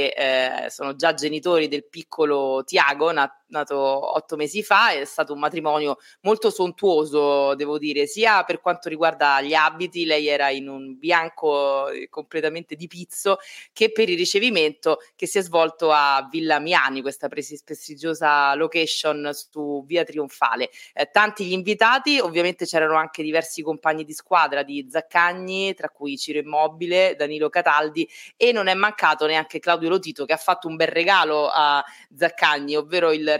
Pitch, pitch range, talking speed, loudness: 155 Hz, 145-175 Hz, 155 wpm, -21 LUFS